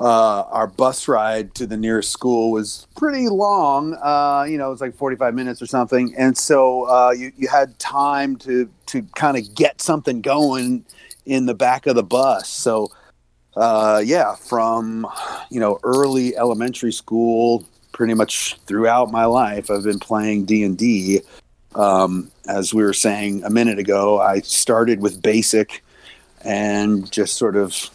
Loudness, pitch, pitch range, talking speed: -18 LUFS, 115 Hz, 105-130 Hz, 165 wpm